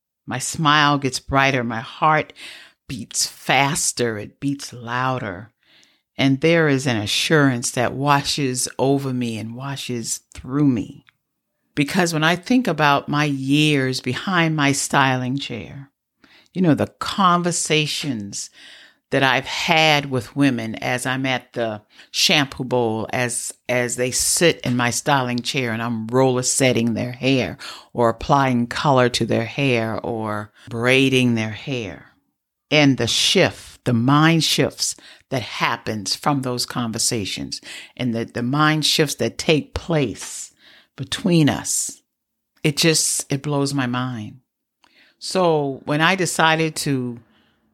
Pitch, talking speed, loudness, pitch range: 130 Hz, 135 wpm, -19 LUFS, 120-145 Hz